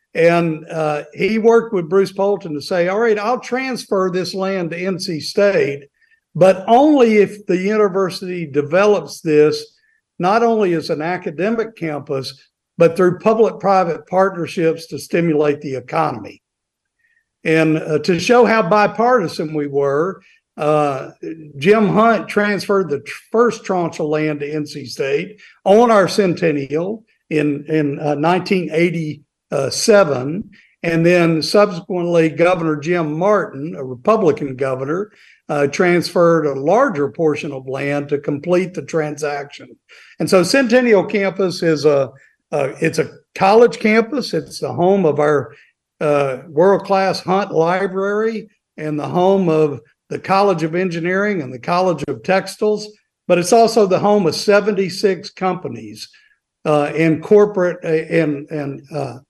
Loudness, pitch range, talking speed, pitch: -16 LUFS, 155-205 Hz, 140 wpm, 180 Hz